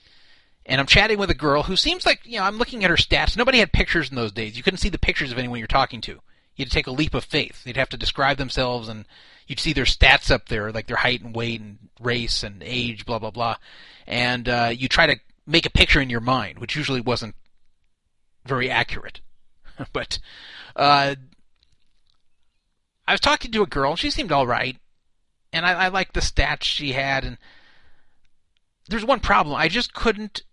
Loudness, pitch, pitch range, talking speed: -21 LUFS, 130 Hz, 115-165 Hz, 205 wpm